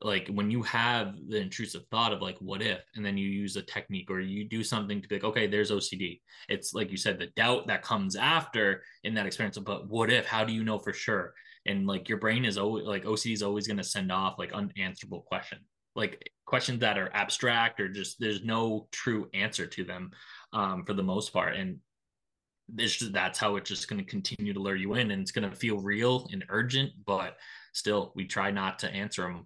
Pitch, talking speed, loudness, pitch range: 105 Hz, 230 wpm, -31 LUFS, 100-115 Hz